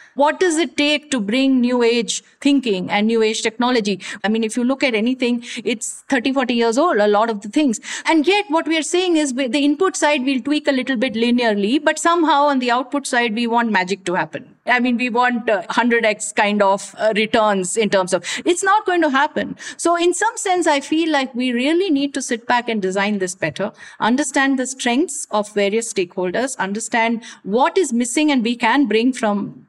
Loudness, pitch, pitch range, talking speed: -18 LUFS, 245 Hz, 220-295 Hz, 215 wpm